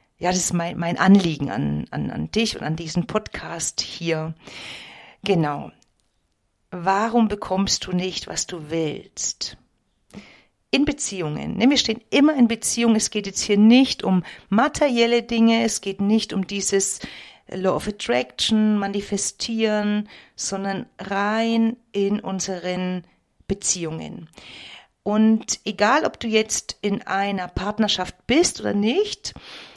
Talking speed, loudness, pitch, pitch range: 125 wpm, -22 LUFS, 200 Hz, 180-220 Hz